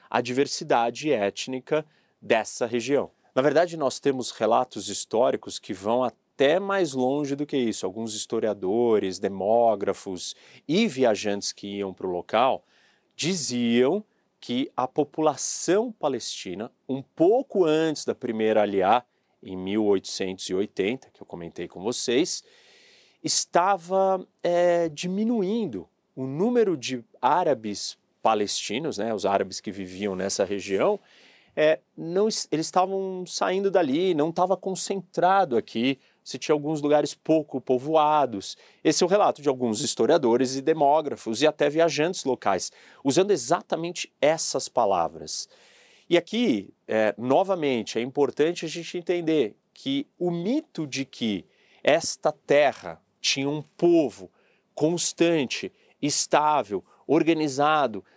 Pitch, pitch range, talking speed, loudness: 150 Hz, 120-185 Hz, 120 wpm, -25 LUFS